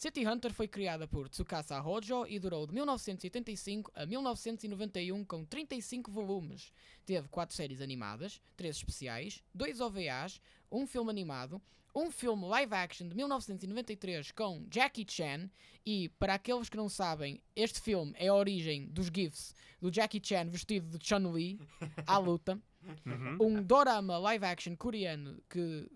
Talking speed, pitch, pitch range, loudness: 145 wpm, 195 Hz, 170-220 Hz, -37 LUFS